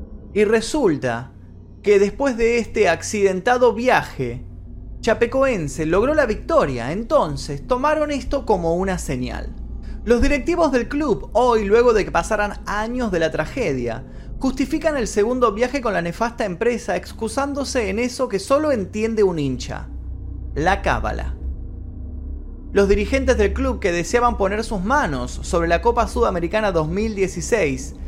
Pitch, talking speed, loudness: 205 Hz, 135 wpm, -20 LUFS